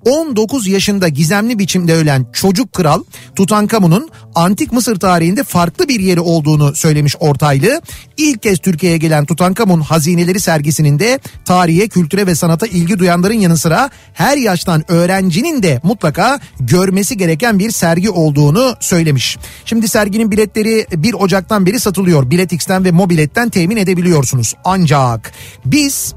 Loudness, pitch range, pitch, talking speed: -12 LUFS, 165-210 Hz, 180 Hz, 135 wpm